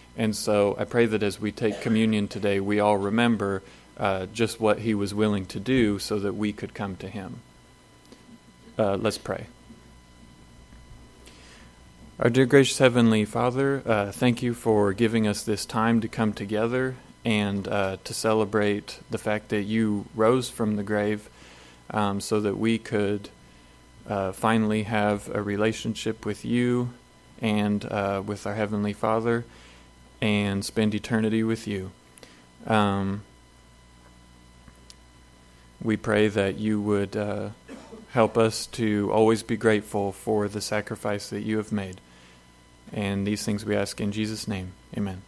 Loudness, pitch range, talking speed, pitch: -26 LUFS, 100-110 Hz, 145 wpm, 105 Hz